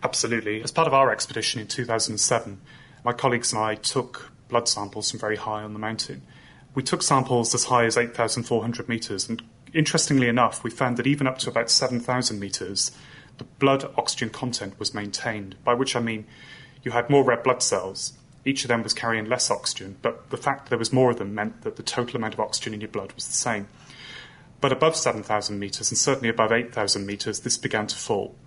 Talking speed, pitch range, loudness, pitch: 205 wpm, 110-130 Hz, -24 LUFS, 120 Hz